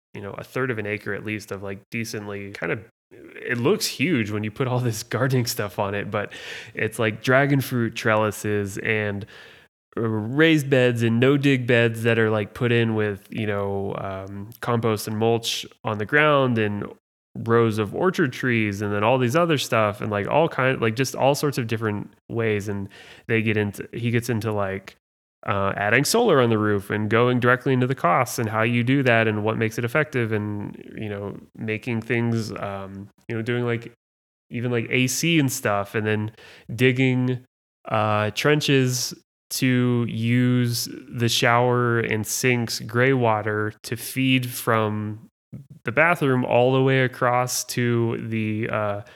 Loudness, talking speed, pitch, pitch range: -22 LUFS, 180 wpm, 115 Hz, 105-125 Hz